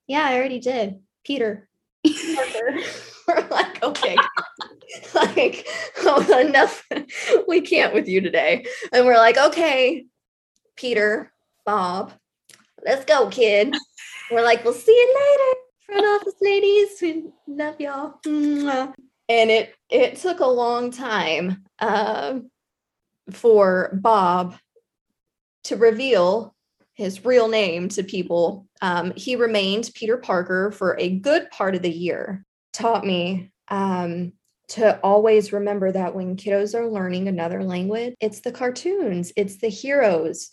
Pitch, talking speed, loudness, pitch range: 230 Hz, 125 wpm, -20 LUFS, 195-285 Hz